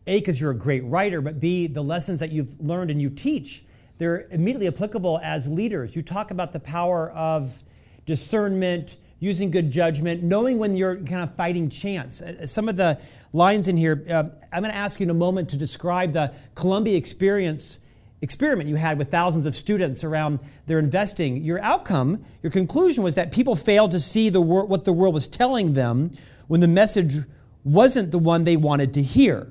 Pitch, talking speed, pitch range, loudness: 170 Hz, 195 wpm, 150-190 Hz, -22 LUFS